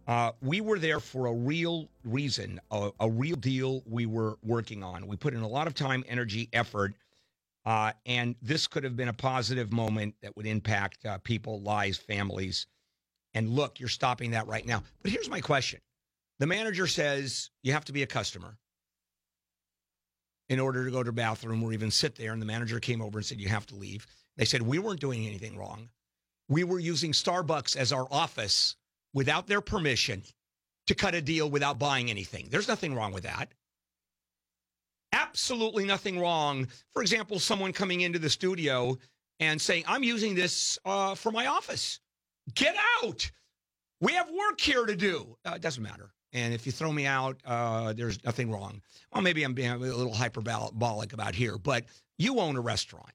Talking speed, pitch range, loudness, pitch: 190 wpm, 110-150 Hz, -30 LUFS, 120 Hz